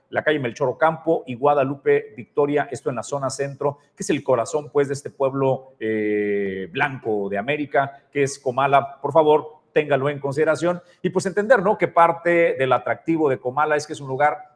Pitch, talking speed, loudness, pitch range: 145 Hz, 190 wpm, -21 LUFS, 130-155 Hz